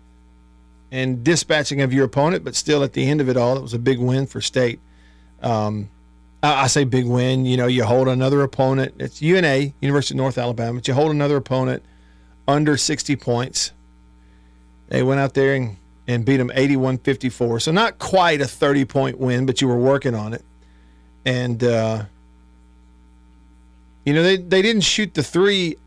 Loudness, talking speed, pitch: -19 LUFS, 180 wpm, 130 Hz